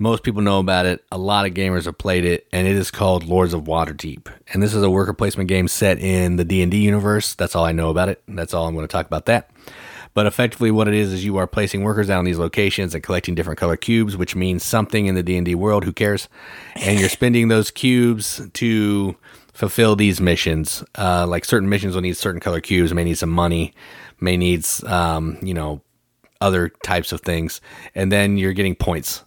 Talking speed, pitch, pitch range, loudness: 230 wpm, 95 Hz, 85-105 Hz, -19 LUFS